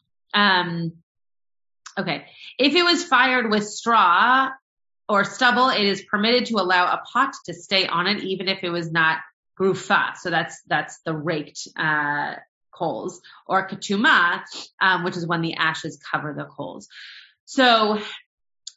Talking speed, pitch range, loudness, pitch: 145 wpm, 170-230 Hz, -21 LUFS, 195 Hz